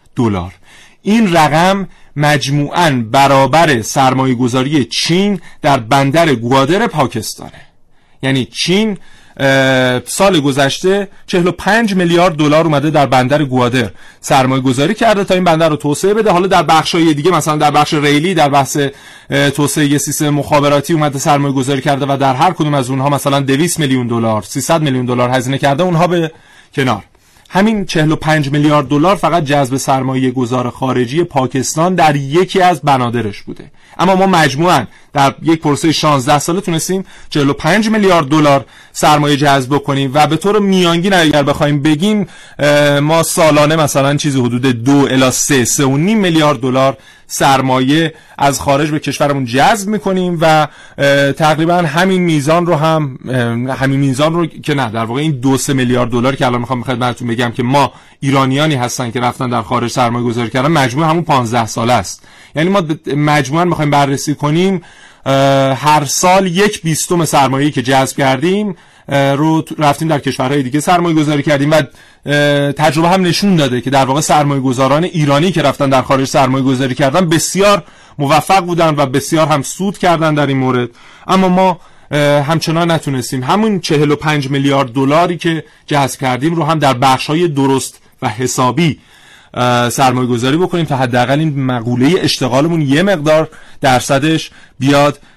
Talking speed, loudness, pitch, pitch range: 155 wpm, -12 LUFS, 145 Hz, 135-165 Hz